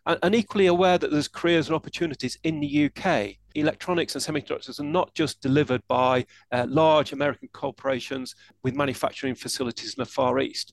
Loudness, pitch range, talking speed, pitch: -25 LUFS, 130-160 Hz, 170 wpm, 145 Hz